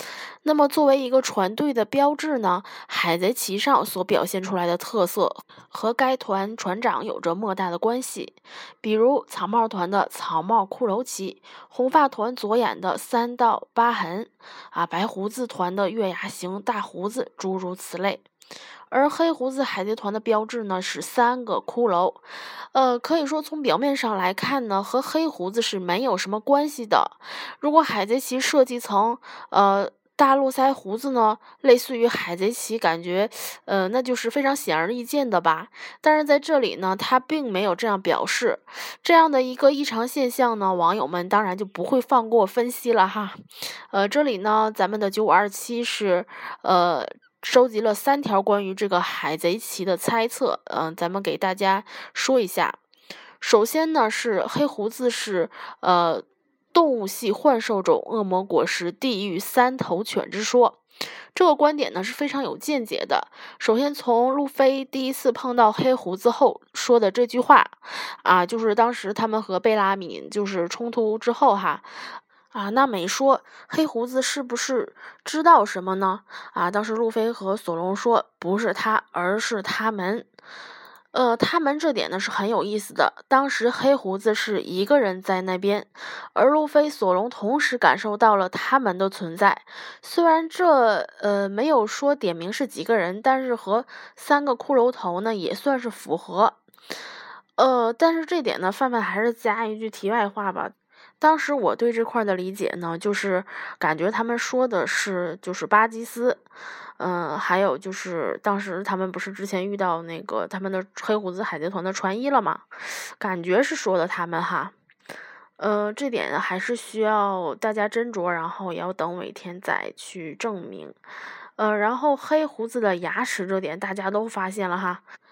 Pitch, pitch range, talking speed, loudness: 220 Hz, 190-260 Hz, 245 characters per minute, -23 LUFS